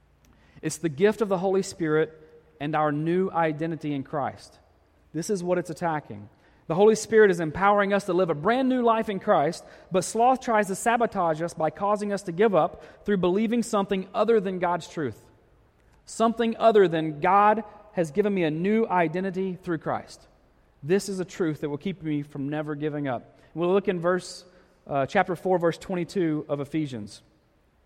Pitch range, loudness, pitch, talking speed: 155-205 Hz, -25 LUFS, 180 Hz, 185 wpm